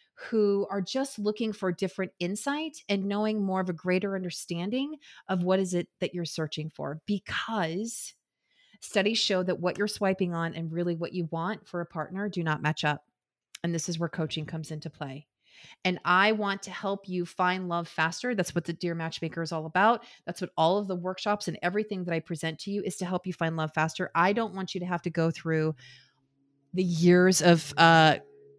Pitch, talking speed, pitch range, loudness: 180 Hz, 210 wpm, 165-200 Hz, -28 LUFS